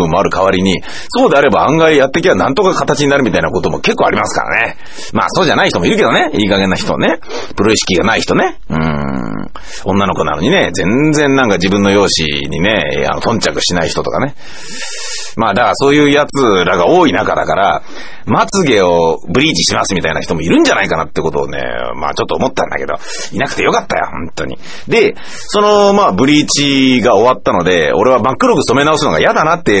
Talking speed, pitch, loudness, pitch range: 425 characters per minute, 120 Hz, -11 LUFS, 90-145 Hz